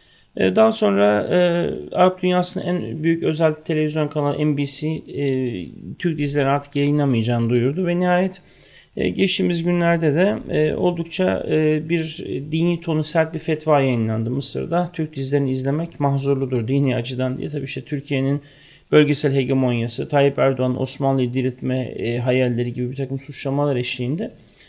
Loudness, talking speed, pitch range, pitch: -20 LUFS, 140 wpm, 130-165 Hz, 145 Hz